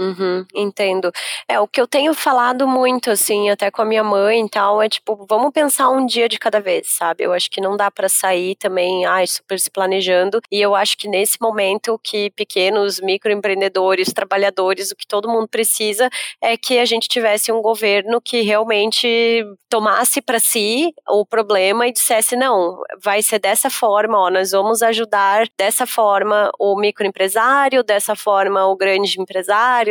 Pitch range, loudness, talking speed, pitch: 195-230 Hz, -16 LUFS, 175 wpm, 210 Hz